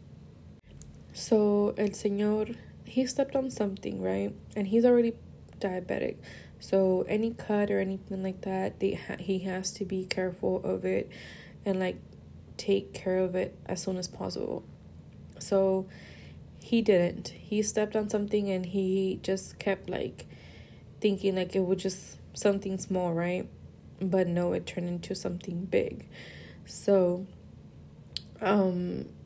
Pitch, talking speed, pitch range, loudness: 190 Hz, 135 wpm, 180-205 Hz, -30 LUFS